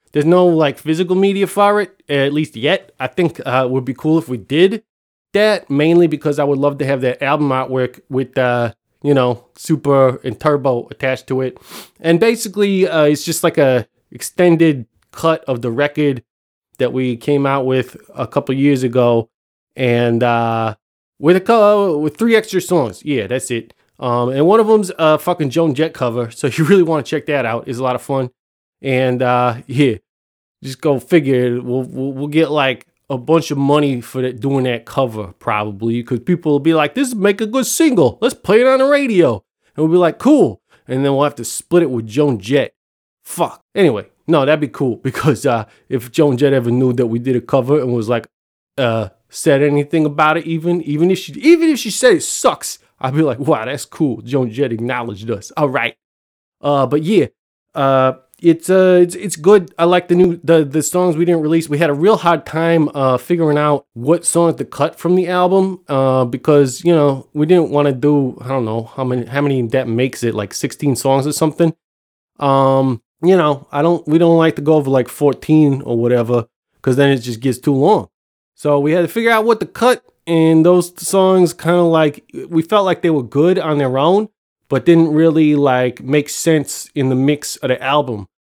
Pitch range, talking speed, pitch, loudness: 130-170 Hz, 215 wpm, 145 Hz, -15 LUFS